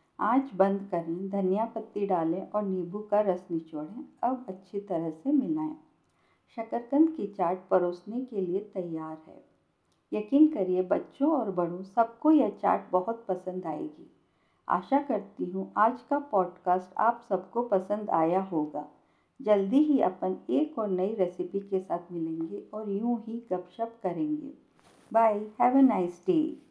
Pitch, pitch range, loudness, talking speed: 205 Hz, 185-245 Hz, -29 LUFS, 150 wpm